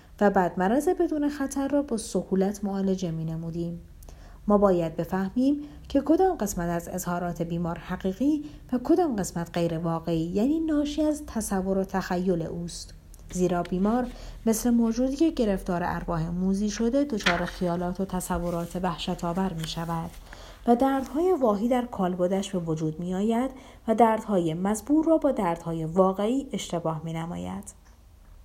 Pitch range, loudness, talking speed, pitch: 170-240 Hz, -27 LUFS, 145 wpm, 190 Hz